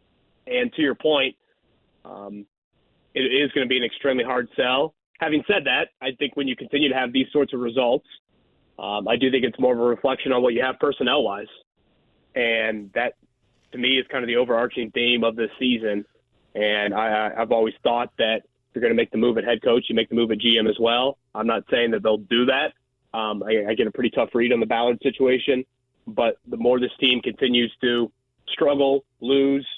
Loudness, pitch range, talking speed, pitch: -22 LUFS, 115-130 Hz, 215 wpm, 125 Hz